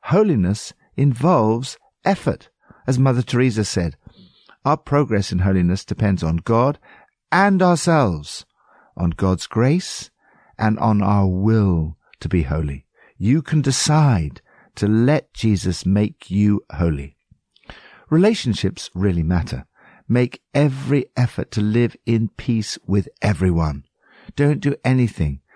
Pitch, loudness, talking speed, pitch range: 110 Hz, -19 LUFS, 115 wpm, 90-135 Hz